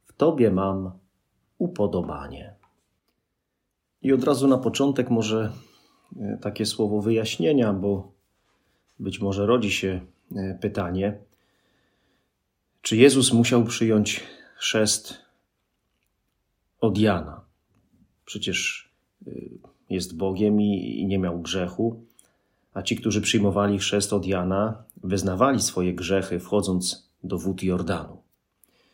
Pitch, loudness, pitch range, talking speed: 100 Hz, -24 LUFS, 95-110 Hz, 95 wpm